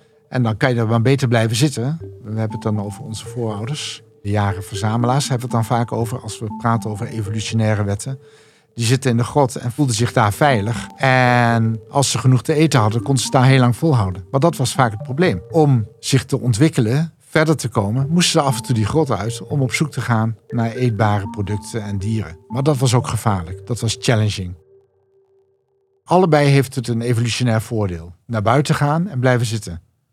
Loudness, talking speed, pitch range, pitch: -18 LUFS, 210 wpm, 110-140 Hz, 120 Hz